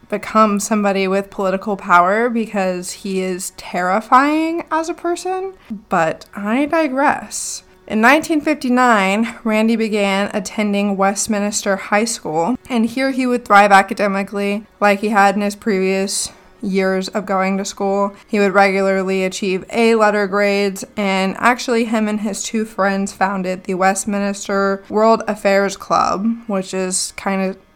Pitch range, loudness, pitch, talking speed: 195-225 Hz, -17 LUFS, 205 Hz, 140 wpm